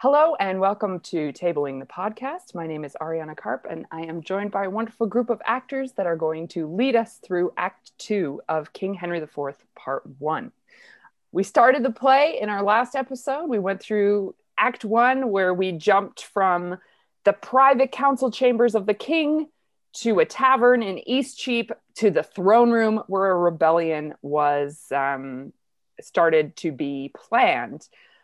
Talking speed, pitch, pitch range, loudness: 170 wpm, 200 Hz, 165-245 Hz, -23 LUFS